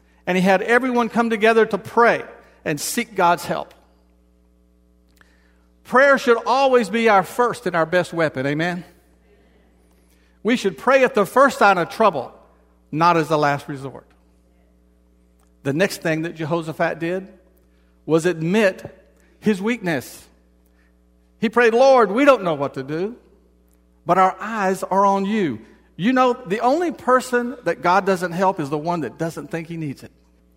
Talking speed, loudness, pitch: 155 wpm, -19 LUFS, 170 Hz